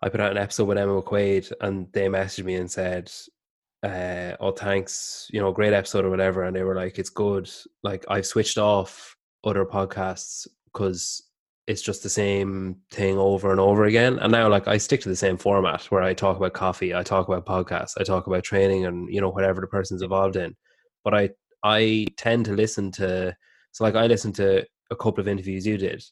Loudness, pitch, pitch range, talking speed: -24 LUFS, 95 Hz, 95-105 Hz, 215 wpm